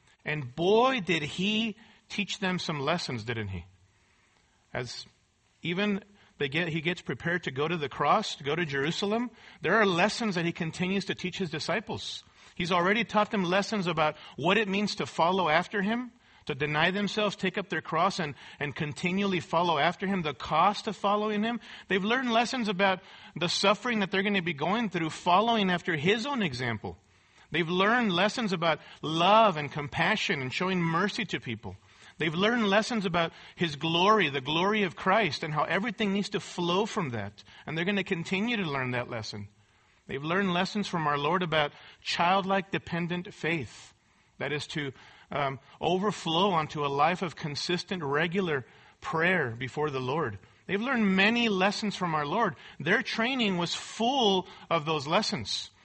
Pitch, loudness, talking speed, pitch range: 180 Hz, -28 LUFS, 175 wpm, 150-205 Hz